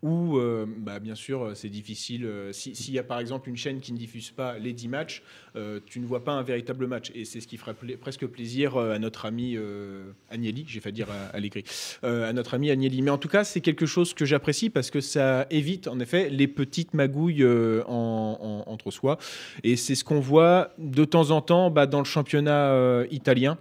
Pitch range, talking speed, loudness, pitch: 115-145 Hz, 235 wpm, -26 LUFS, 125 Hz